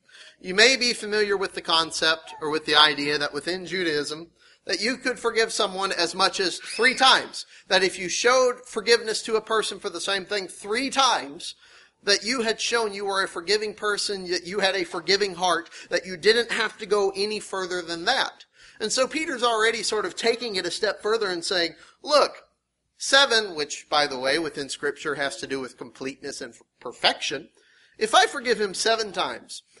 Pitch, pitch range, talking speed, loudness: 205 Hz, 175-230 Hz, 195 wpm, -23 LUFS